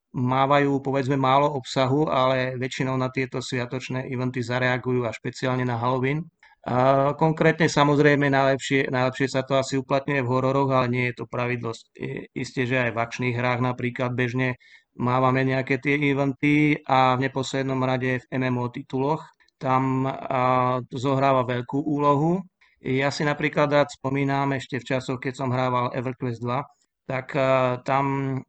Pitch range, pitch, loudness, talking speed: 125-140 Hz, 130 Hz, -24 LUFS, 145 wpm